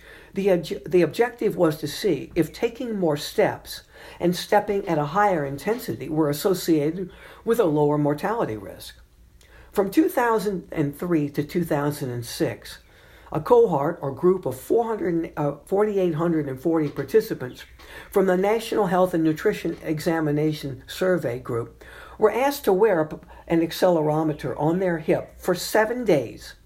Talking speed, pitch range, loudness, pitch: 125 wpm, 150-200 Hz, -23 LUFS, 170 Hz